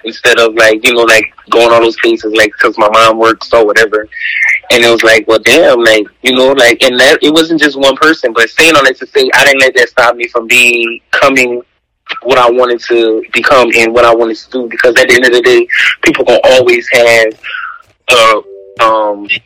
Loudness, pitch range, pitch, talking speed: -6 LUFS, 110-130 Hz, 115 Hz, 225 wpm